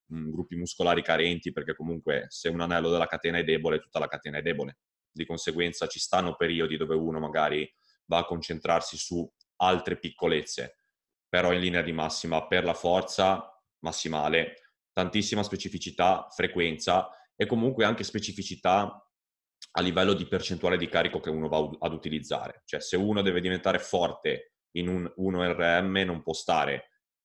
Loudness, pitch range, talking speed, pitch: -29 LUFS, 80-95 Hz, 155 wpm, 85 Hz